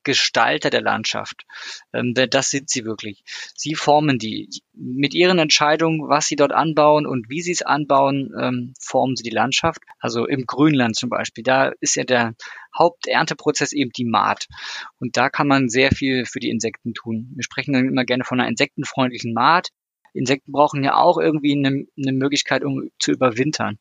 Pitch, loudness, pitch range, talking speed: 135 Hz, -19 LUFS, 125-150 Hz, 175 wpm